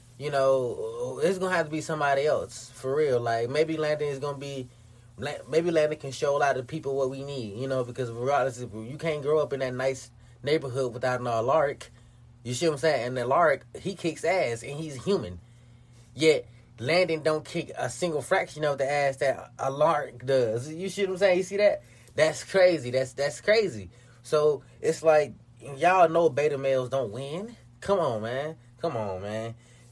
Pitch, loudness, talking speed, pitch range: 140 Hz, -27 LUFS, 200 wpm, 120-155 Hz